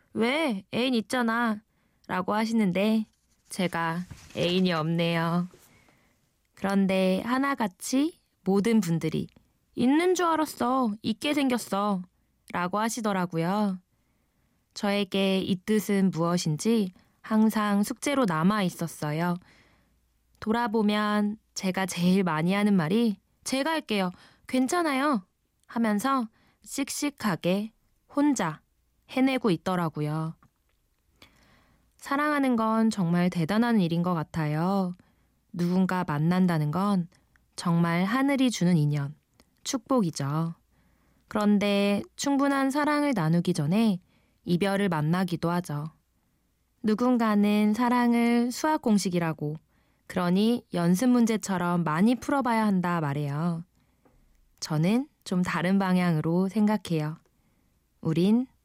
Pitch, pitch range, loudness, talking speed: 195 Hz, 175-230 Hz, -27 LUFS, 225 characters per minute